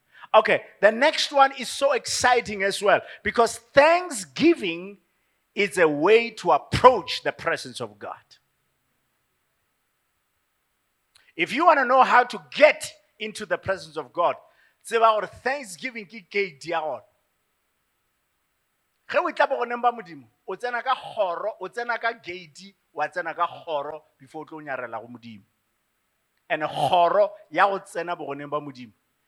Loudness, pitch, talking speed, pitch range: -23 LUFS, 210 Hz, 100 wpm, 170-260 Hz